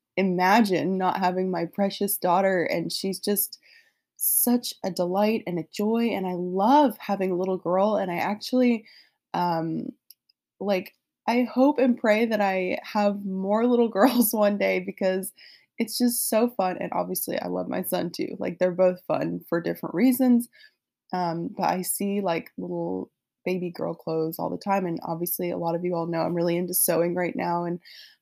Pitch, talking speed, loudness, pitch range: 190 Hz, 180 wpm, -25 LUFS, 175-225 Hz